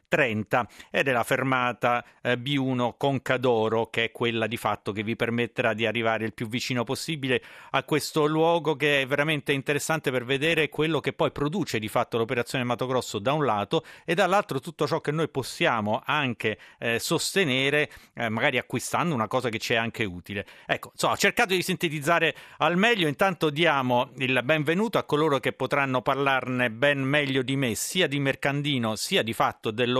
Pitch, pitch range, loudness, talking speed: 135 Hz, 120-150 Hz, -25 LUFS, 180 wpm